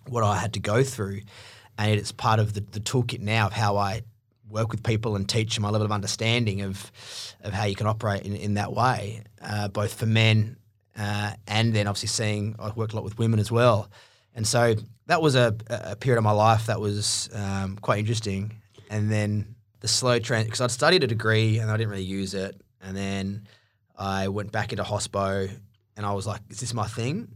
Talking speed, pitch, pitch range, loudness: 220 wpm, 110 Hz, 105-115 Hz, -25 LUFS